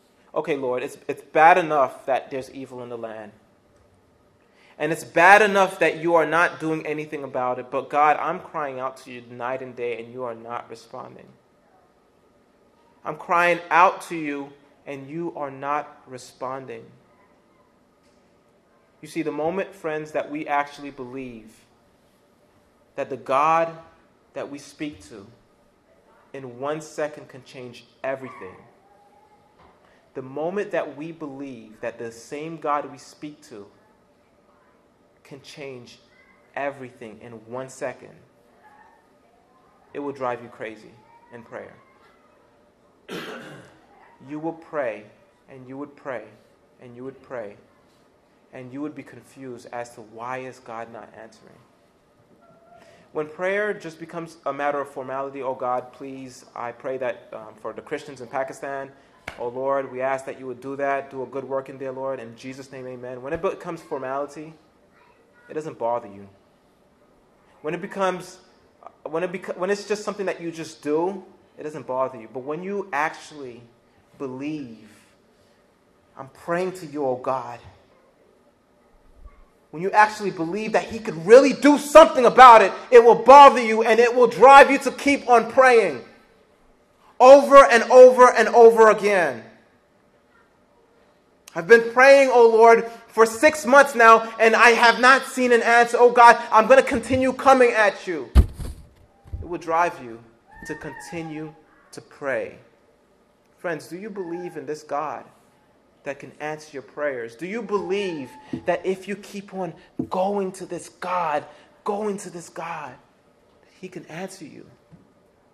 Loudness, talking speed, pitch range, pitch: -18 LUFS, 150 wpm, 130-200 Hz, 150 Hz